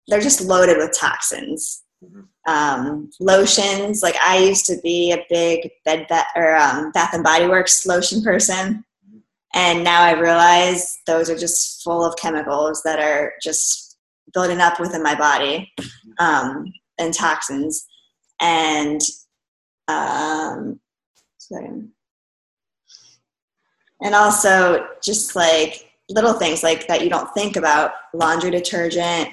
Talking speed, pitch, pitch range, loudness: 125 wpm, 170 Hz, 160-185 Hz, -17 LUFS